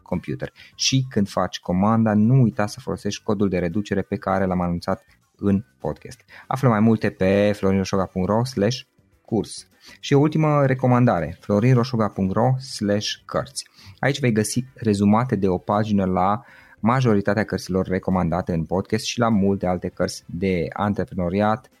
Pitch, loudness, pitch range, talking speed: 105 Hz, -22 LUFS, 95-115 Hz, 140 wpm